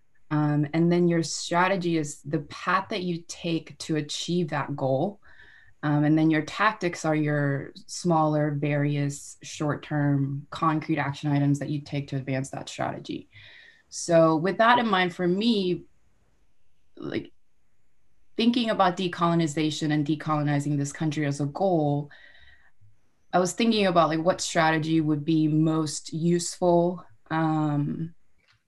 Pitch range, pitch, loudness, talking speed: 145-175 Hz, 155 Hz, -25 LUFS, 140 wpm